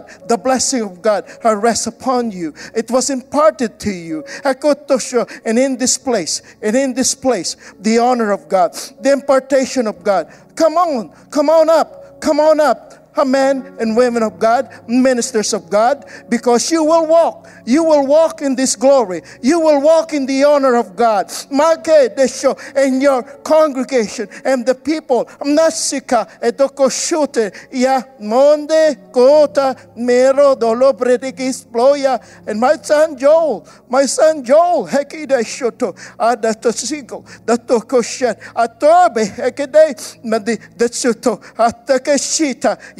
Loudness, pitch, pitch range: -15 LUFS, 265 Hz, 235-290 Hz